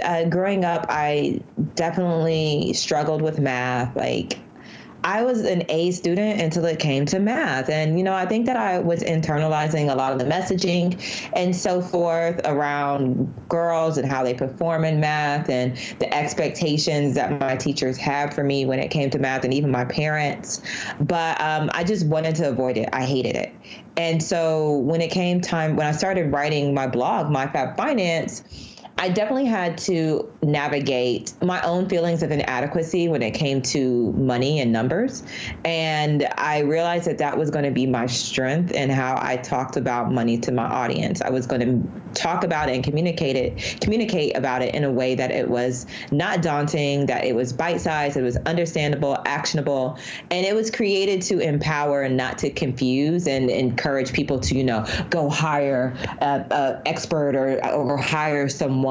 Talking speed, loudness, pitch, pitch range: 180 wpm, -22 LUFS, 150 Hz, 130-170 Hz